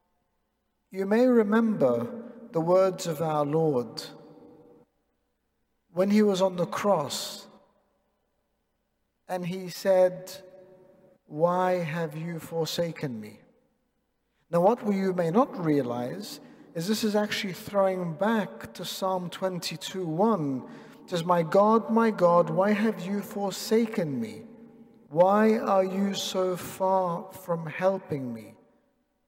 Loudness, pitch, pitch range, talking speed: -27 LUFS, 190 Hz, 170-205 Hz, 115 wpm